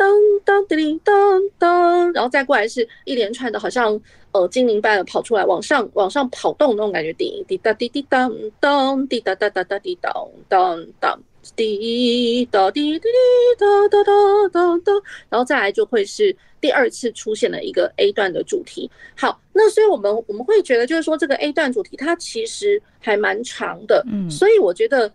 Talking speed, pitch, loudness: 270 characters per minute, 340 Hz, -18 LUFS